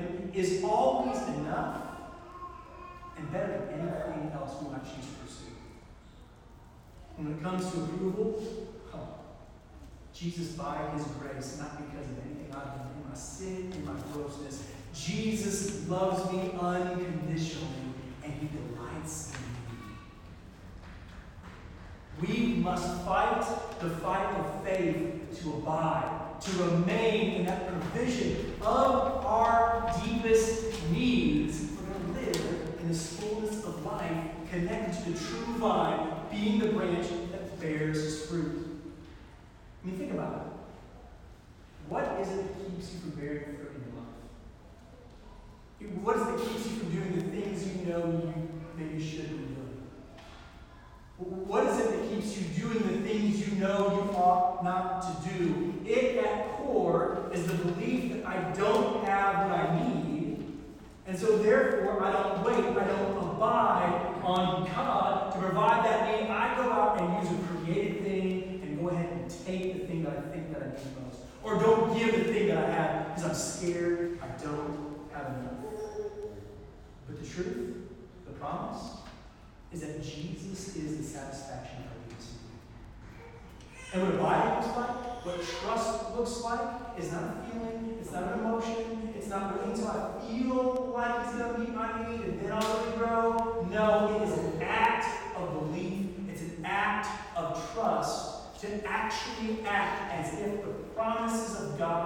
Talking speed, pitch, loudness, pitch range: 155 wpm, 185 Hz, -32 LUFS, 160-220 Hz